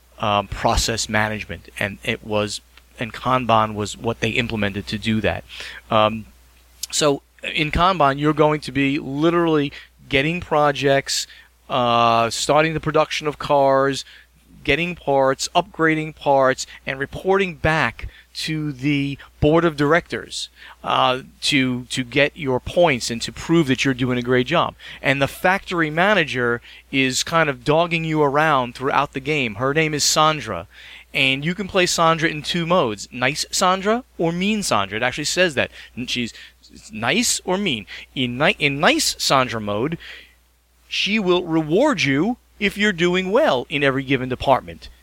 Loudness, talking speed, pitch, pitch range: -20 LUFS, 155 wpm, 140 Hz, 120-165 Hz